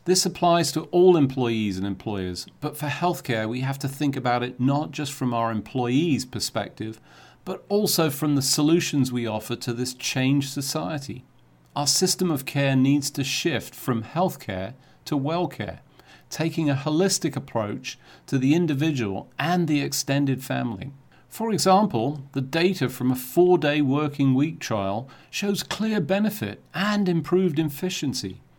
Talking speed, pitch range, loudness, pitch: 150 wpm, 125-165 Hz, -24 LUFS, 140 Hz